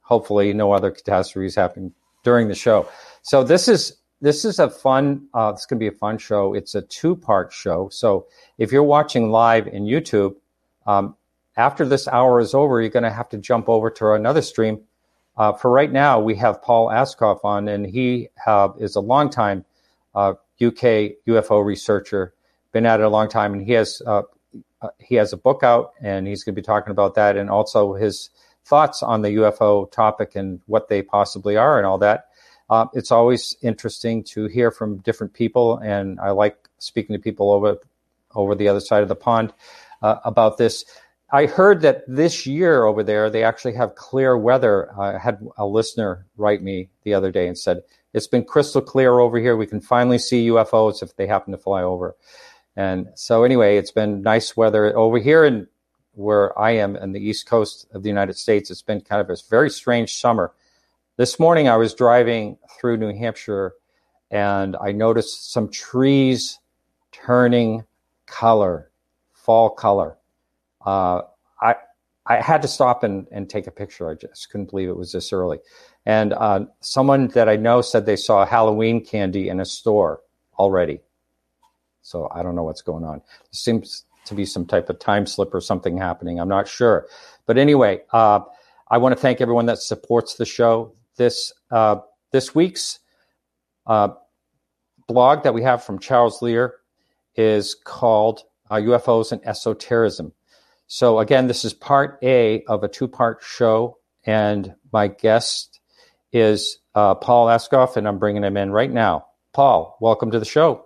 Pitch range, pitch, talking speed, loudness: 100-120 Hz, 110 Hz, 185 wpm, -19 LUFS